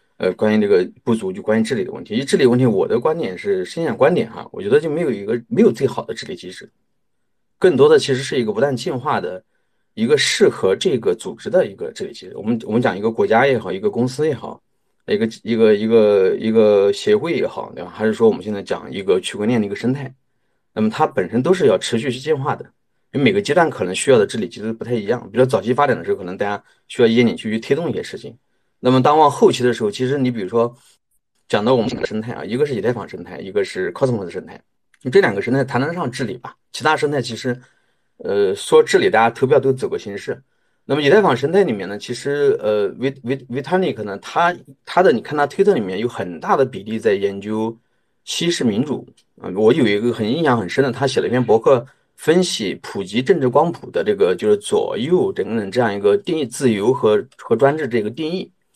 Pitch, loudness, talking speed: 145 Hz, -18 LUFS, 360 characters per minute